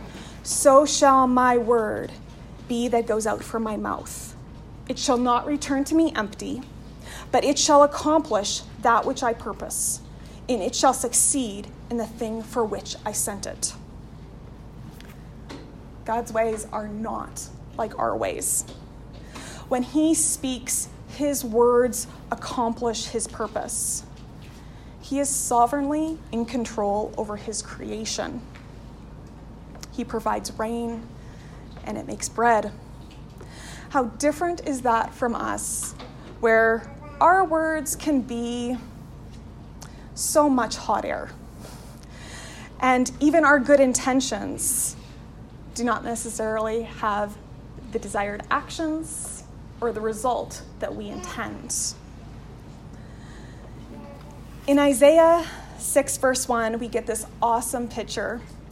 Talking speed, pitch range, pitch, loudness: 115 wpm, 225-280 Hz, 245 Hz, -23 LUFS